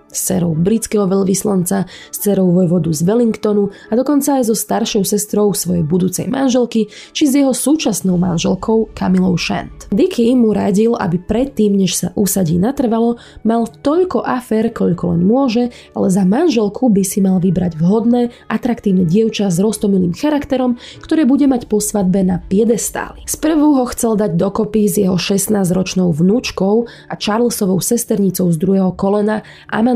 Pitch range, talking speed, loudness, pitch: 190-235 Hz, 150 wpm, -15 LUFS, 210 Hz